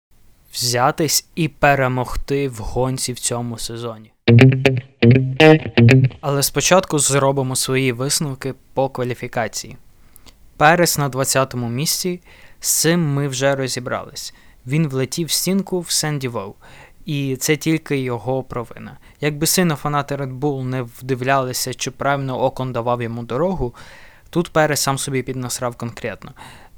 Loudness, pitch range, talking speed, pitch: -18 LUFS, 125-150 Hz, 125 wpm, 135 Hz